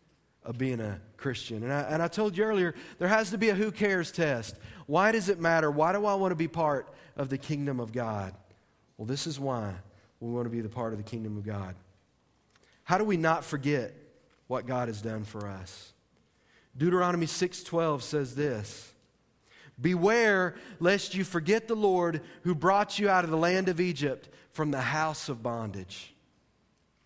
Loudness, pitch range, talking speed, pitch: -29 LUFS, 115-180 Hz, 190 wpm, 150 Hz